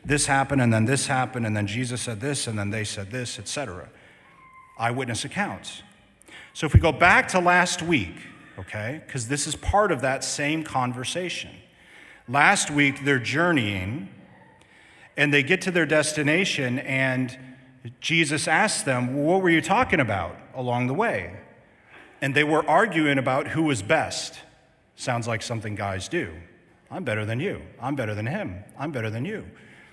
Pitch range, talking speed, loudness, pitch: 120-160 Hz, 170 wpm, -24 LUFS, 135 Hz